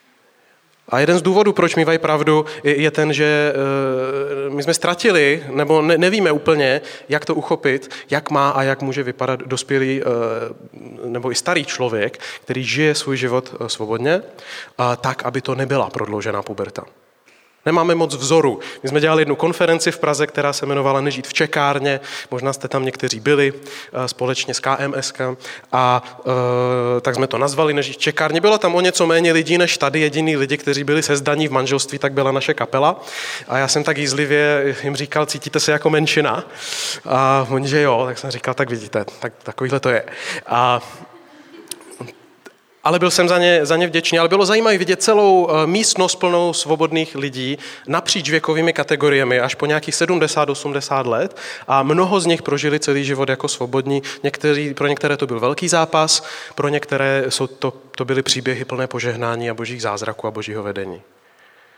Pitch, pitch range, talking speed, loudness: 140 Hz, 130-160 Hz, 170 wpm, -18 LUFS